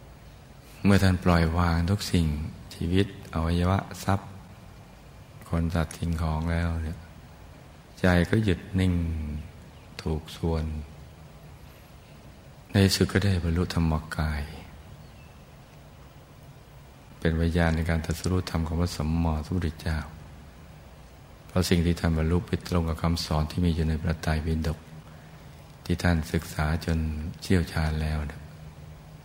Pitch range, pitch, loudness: 80-90 Hz, 85 Hz, -27 LUFS